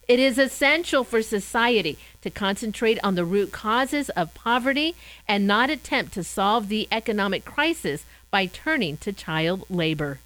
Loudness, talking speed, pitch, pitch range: -23 LUFS, 150 wpm, 215 Hz, 195-260 Hz